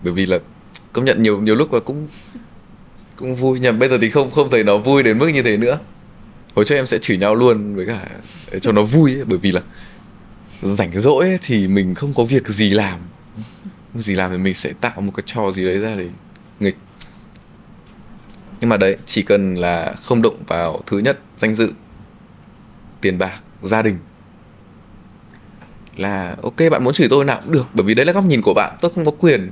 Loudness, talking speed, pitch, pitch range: -17 LUFS, 215 wpm, 110 Hz, 95-130 Hz